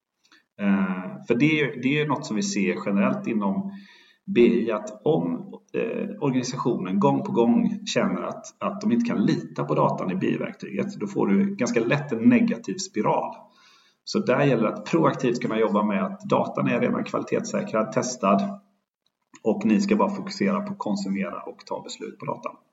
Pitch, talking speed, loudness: 195 Hz, 170 wpm, -24 LUFS